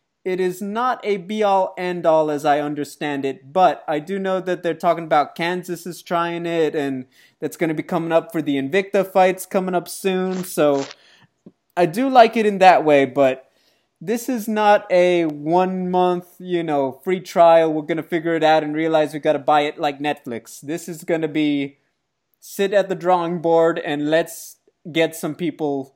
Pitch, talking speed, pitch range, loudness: 170 Hz, 190 wpm, 150-185 Hz, -19 LUFS